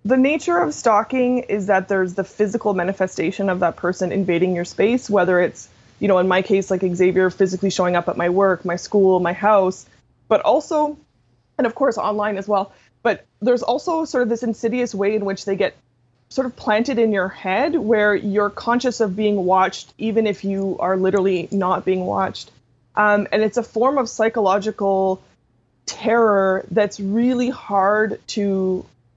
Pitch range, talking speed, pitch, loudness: 185-225 Hz, 180 wpm, 200 Hz, -19 LUFS